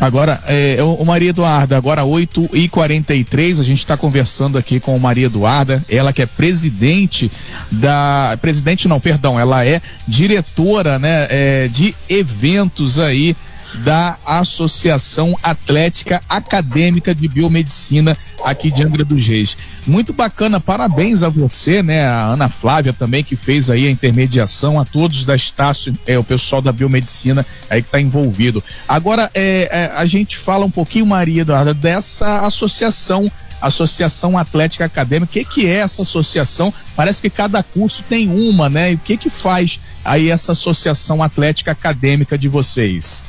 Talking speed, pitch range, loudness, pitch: 155 wpm, 135-175 Hz, -14 LUFS, 155 Hz